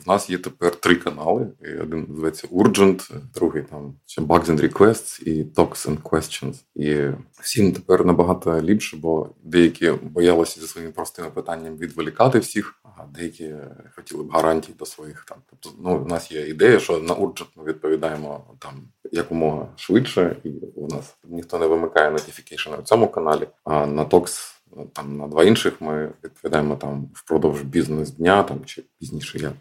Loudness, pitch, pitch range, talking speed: -21 LUFS, 80 Hz, 75-85 Hz, 165 wpm